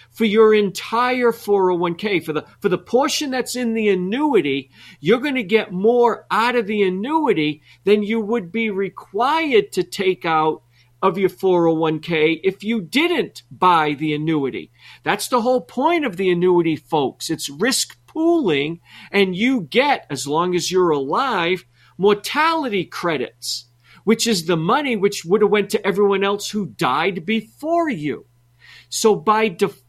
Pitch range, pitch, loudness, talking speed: 165-230 Hz, 200 Hz, -19 LUFS, 155 wpm